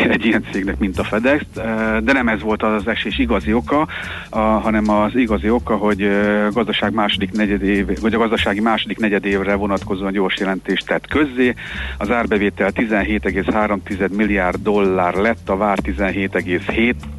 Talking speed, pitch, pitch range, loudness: 150 wpm, 105 Hz, 100-110 Hz, -18 LUFS